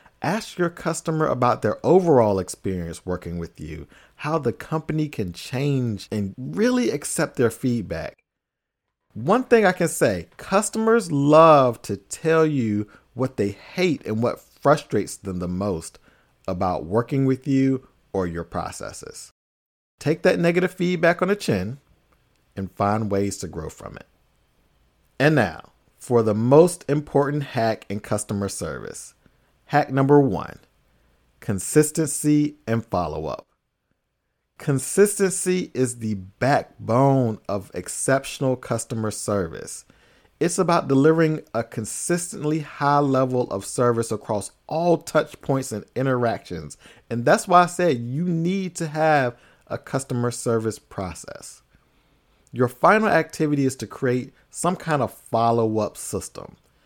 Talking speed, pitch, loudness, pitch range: 130 wpm, 130 Hz, -22 LUFS, 105-155 Hz